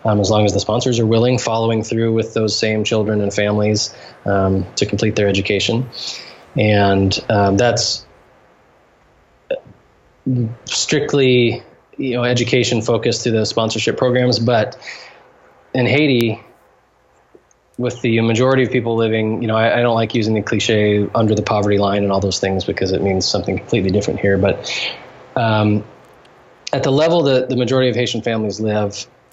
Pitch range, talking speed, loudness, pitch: 105-120 Hz, 160 wpm, -17 LUFS, 110 Hz